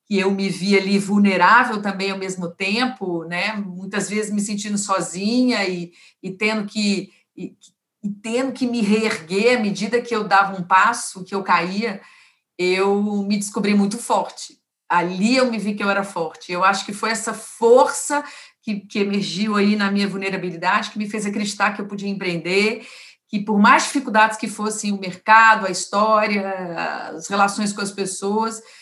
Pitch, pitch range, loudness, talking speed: 205 Hz, 195-220 Hz, -20 LUFS, 175 wpm